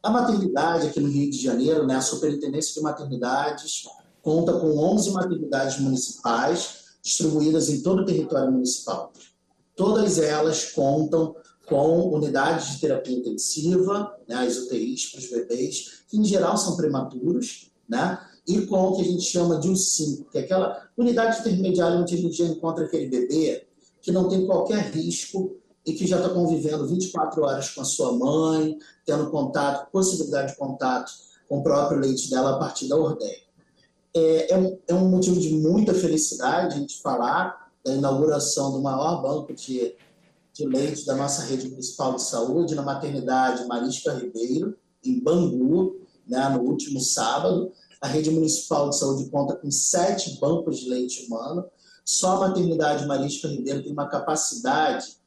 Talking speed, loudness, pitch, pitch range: 165 wpm, -24 LUFS, 155 Hz, 135-180 Hz